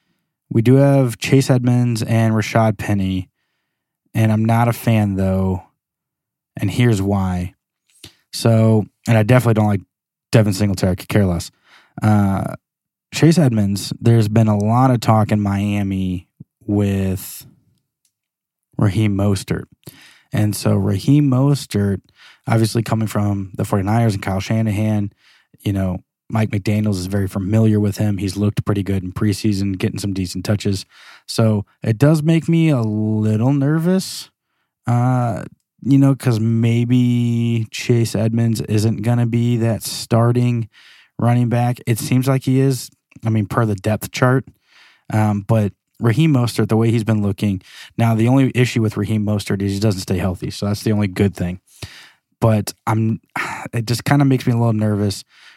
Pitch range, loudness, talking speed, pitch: 100-120 Hz, -18 LUFS, 155 wpm, 110 Hz